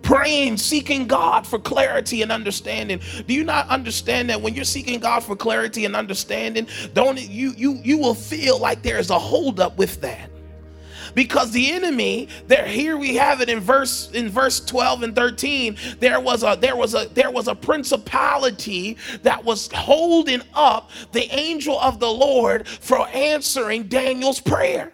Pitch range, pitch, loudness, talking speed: 230-280 Hz, 260 Hz, -20 LUFS, 175 wpm